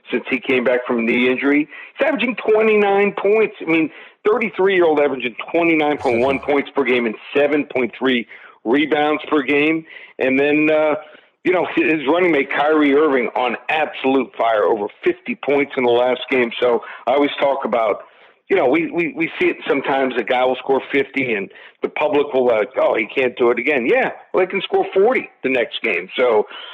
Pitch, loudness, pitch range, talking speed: 150 Hz, -18 LUFS, 130-210 Hz, 205 wpm